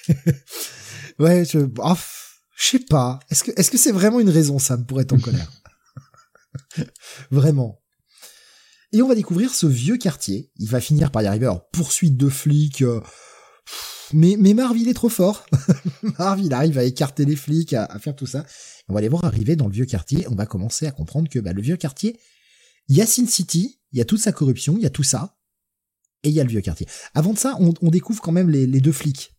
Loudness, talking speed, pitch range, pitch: -19 LUFS, 220 wpm, 130-190 Hz, 155 Hz